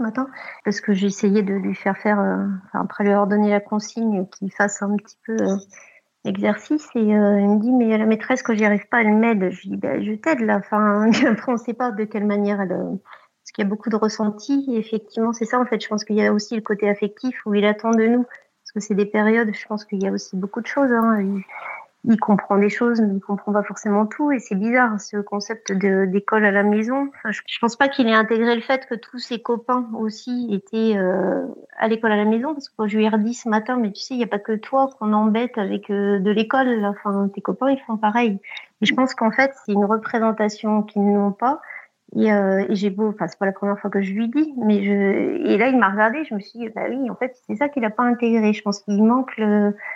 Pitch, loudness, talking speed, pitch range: 215 Hz, -20 LUFS, 260 wpm, 205-235 Hz